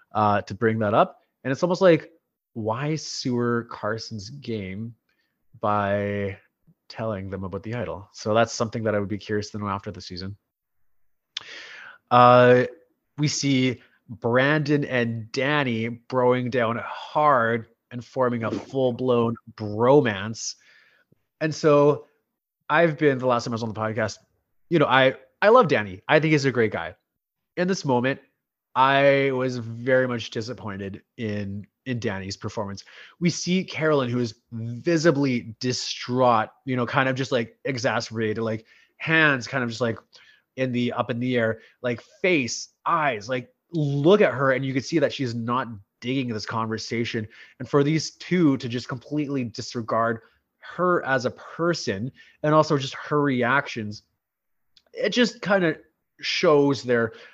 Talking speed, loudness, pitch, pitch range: 155 wpm, -23 LUFS, 125 Hz, 110-140 Hz